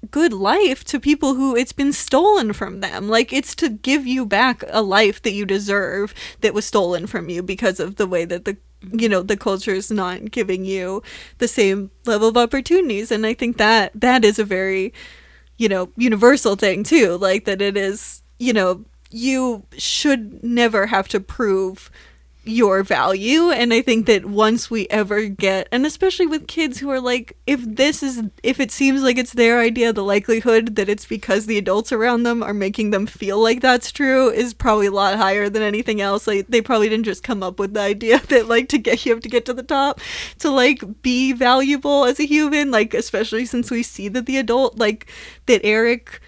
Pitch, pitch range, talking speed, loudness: 225 Hz, 200-255 Hz, 205 wpm, -18 LUFS